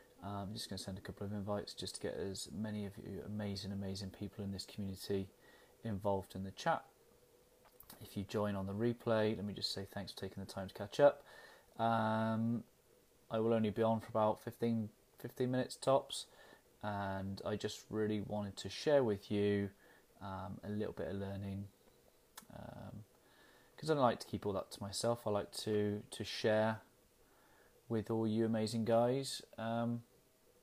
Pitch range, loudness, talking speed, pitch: 100-115 Hz, -39 LUFS, 185 wpm, 105 Hz